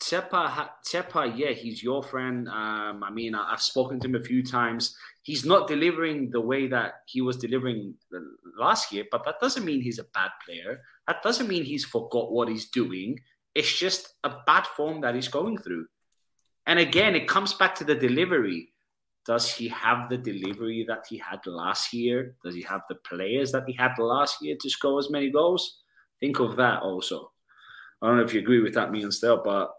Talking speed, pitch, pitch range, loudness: 205 wpm, 125 Hz, 115-145 Hz, -26 LUFS